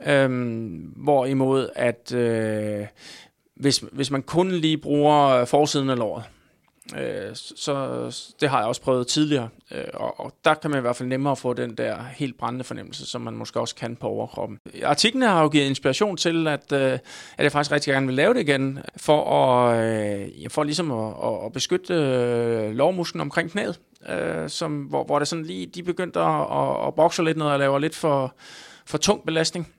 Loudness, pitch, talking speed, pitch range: -23 LUFS, 140 Hz, 190 wpm, 125-155 Hz